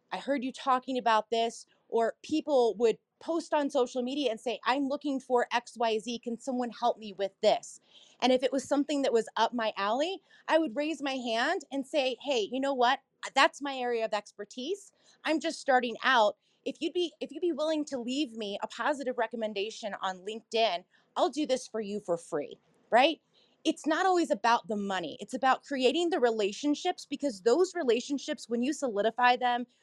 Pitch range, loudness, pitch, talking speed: 225-290 Hz, -30 LUFS, 255 Hz, 195 wpm